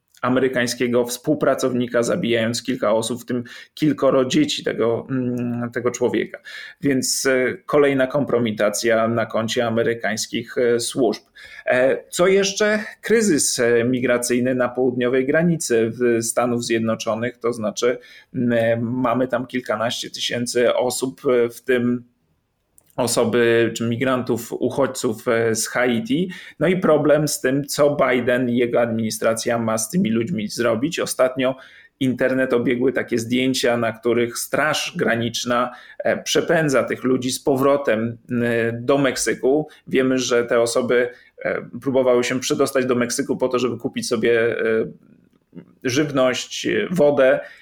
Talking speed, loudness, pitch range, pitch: 115 wpm, -20 LUFS, 120-130 Hz, 125 Hz